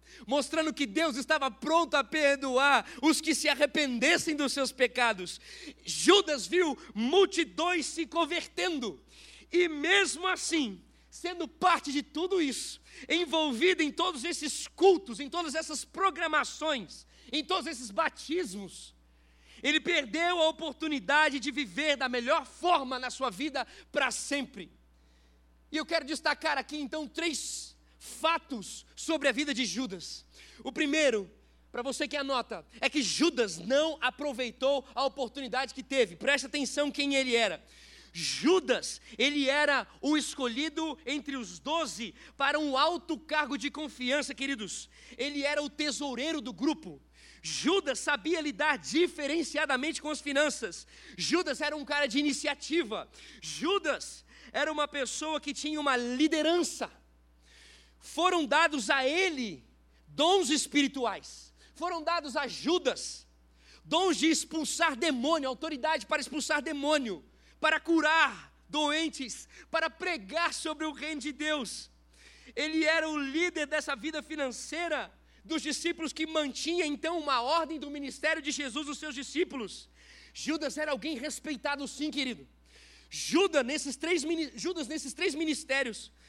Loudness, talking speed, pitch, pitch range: -30 LUFS, 135 wpm, 295 Hz, 265-320 Hz